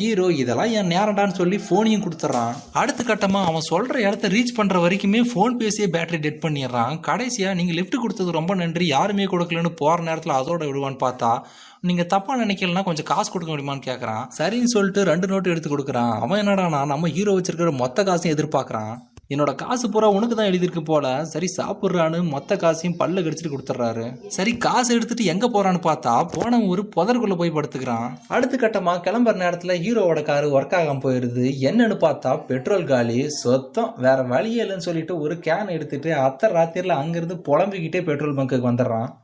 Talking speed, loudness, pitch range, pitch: 165 wpm, -21 LUFS, 145-200 Hz, 170 Hz